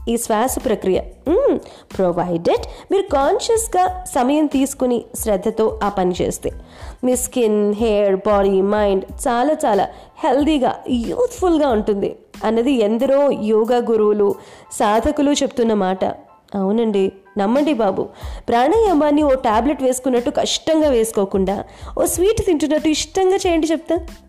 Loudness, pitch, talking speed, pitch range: -18 LUFS, 255 Hz, 110 wpm, 210-310 Hz